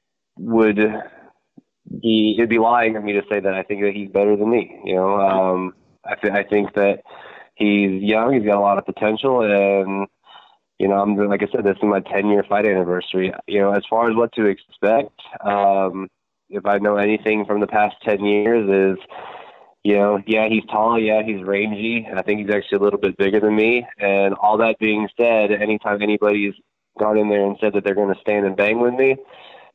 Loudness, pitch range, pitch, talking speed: -18 LUFS, 100-110 Hz, 105 Hz, 215 wpm